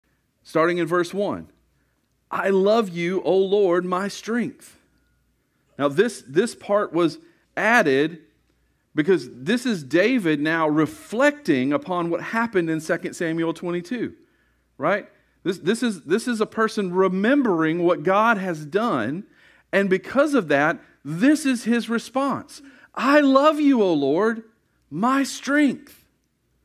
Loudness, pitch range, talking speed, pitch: -22 LUFS, 170-260 Hz, 130 wpm, 205 Hz